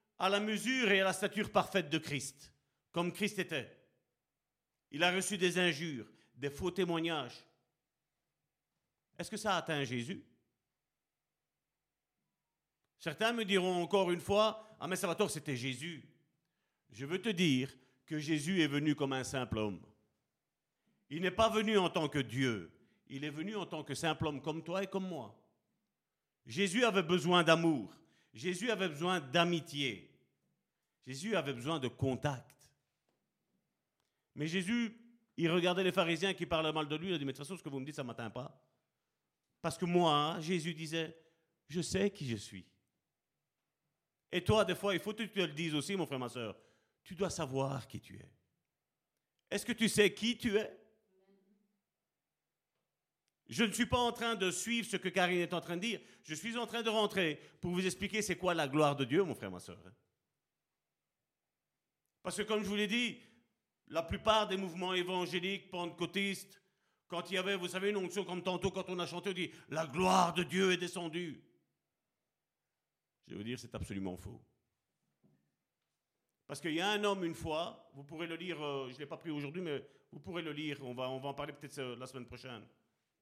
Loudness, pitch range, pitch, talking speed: -36 LUFS, 145-195 Hz, 175 Hz, 185 wpm